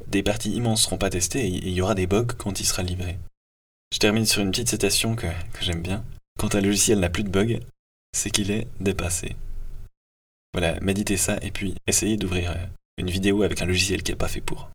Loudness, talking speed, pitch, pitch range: -24 LUFS, 220 wpm, 95 Hz, 90-105 Hz